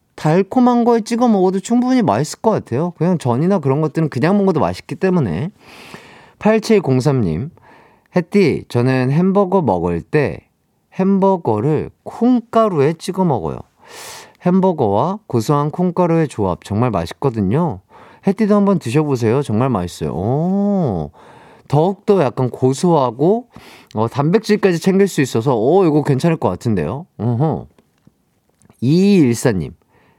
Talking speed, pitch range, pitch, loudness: 270 characters per minute, 130-200 Hz, 165 Hz, -16 LUFS